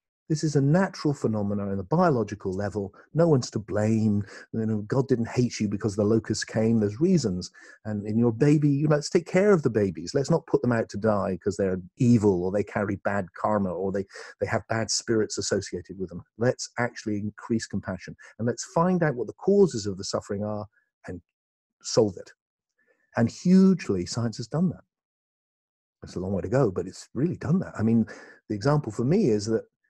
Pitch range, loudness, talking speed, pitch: 105-145 Hz, -26 LUFS, 210 wpm, 110 Hz